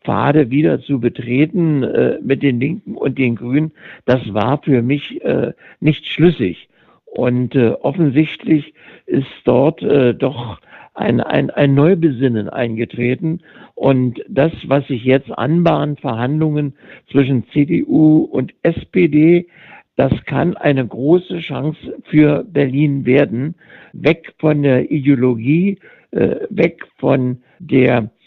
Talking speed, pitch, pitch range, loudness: 120 wpm, 145 Hz, 130-155 Hz, -16 LUFS